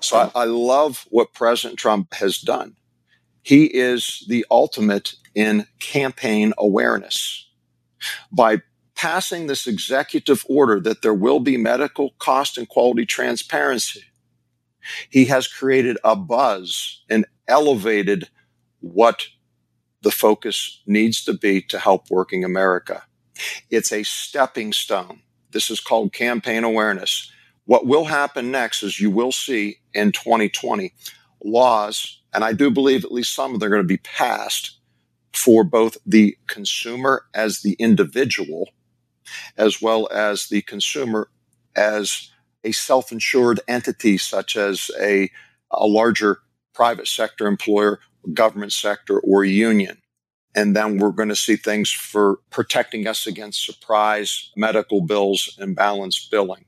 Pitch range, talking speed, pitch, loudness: 100-120 Hz, 130 wpm, 105 Hz, -19 LUFS